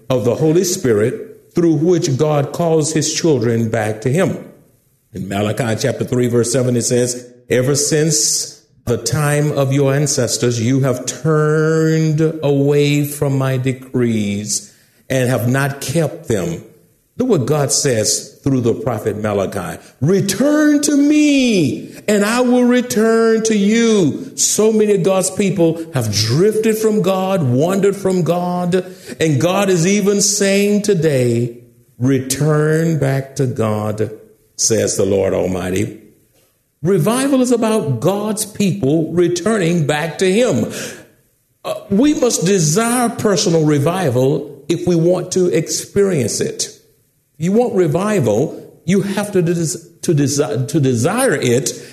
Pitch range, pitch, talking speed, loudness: 130-195 Hz, 155 Hz, 135 wpm, -15 LUFS